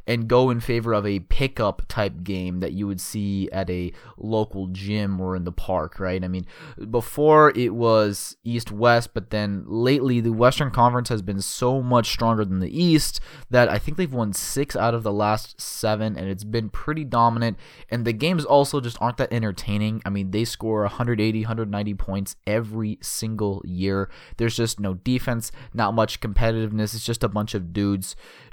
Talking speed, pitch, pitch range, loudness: 190 wpm, 110 Hz, 100-120 Hz, -23 LUFS